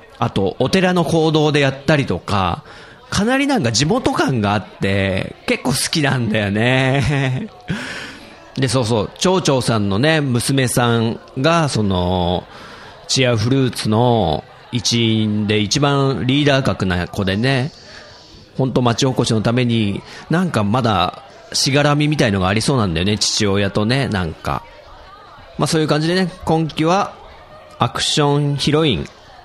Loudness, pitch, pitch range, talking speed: -17 LUFS, 130 Hz, 105-145 Hz, 280 characters per minute